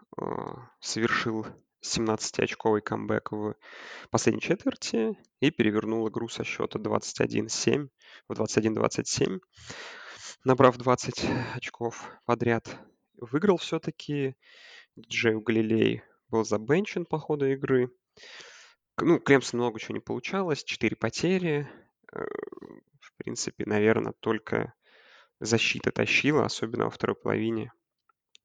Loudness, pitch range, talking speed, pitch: -28 LUFS, 110-170 Hz, 95 wpm, 125 Hz